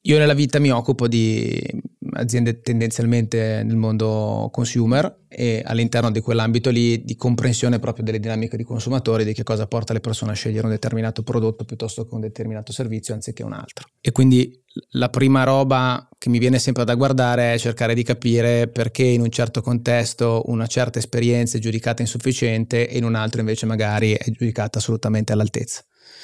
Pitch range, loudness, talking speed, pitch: 115-120 Hz, -20 LUFS, 180 wpm, 120 Hz